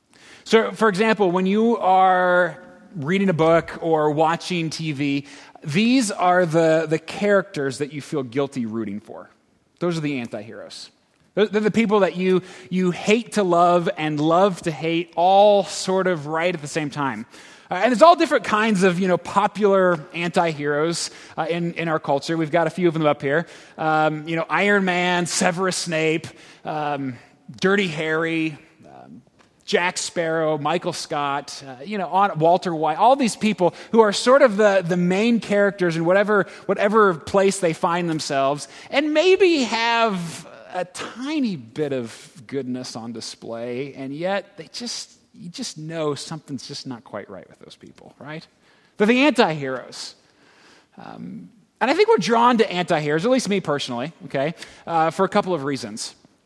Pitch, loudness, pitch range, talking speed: 175 Hz, -20 LUFS, 155-200 Hz, 165 wpm